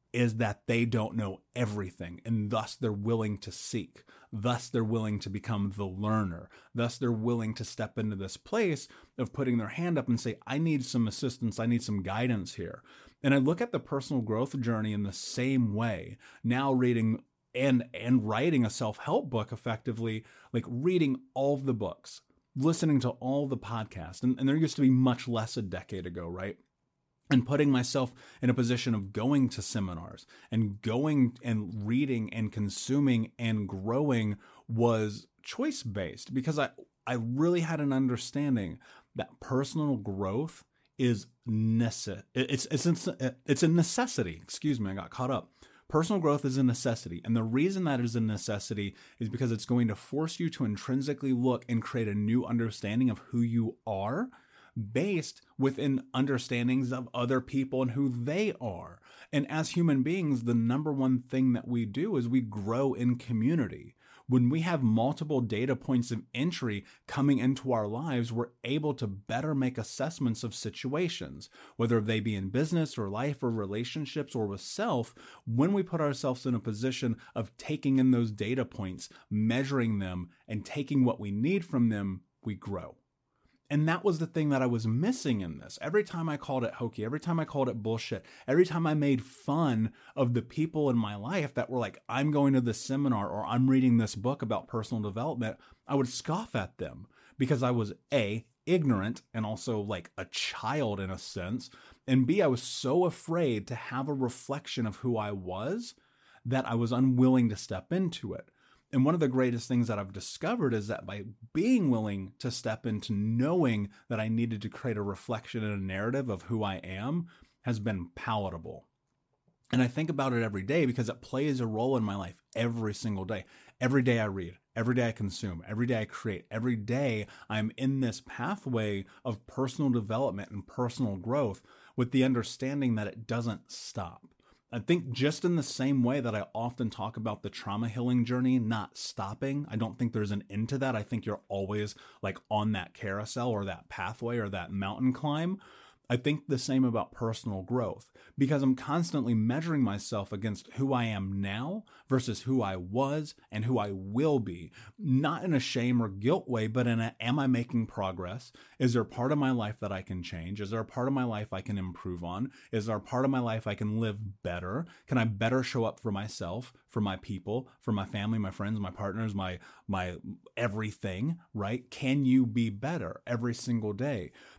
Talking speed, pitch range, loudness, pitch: 190 wpm, 110-135 Hz, -31 LUFS, 120 Hz